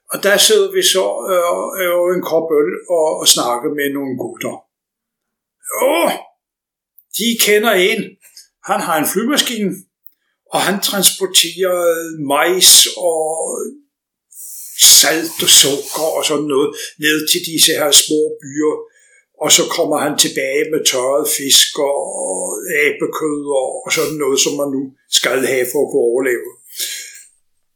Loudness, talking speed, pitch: -13 LUFS, 140 wpm, 190 Hz